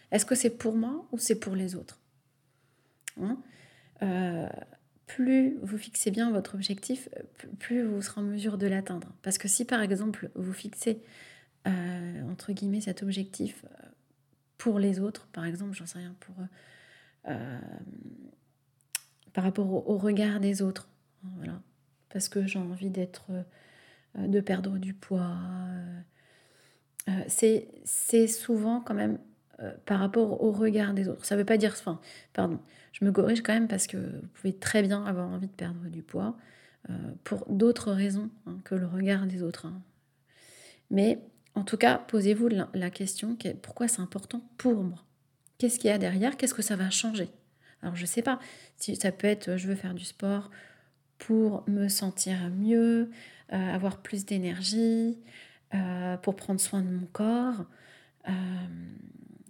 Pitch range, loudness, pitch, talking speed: 180-215 Hz, -30 LUFS, 195 Hz, 165 wpm